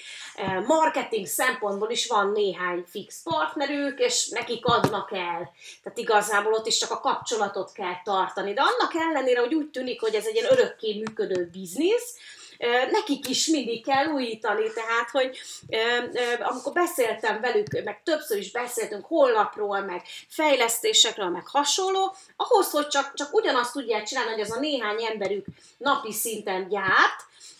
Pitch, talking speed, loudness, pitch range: 245 Hz, 145 wpm, -25 LUFS, 210-320 Hz